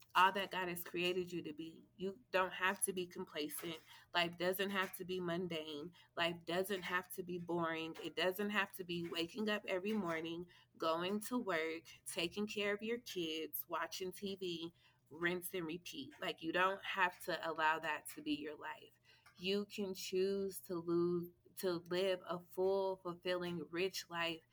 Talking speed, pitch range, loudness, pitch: 175 wpm, 165-190 Hz, -40 LUFS, 180 Hz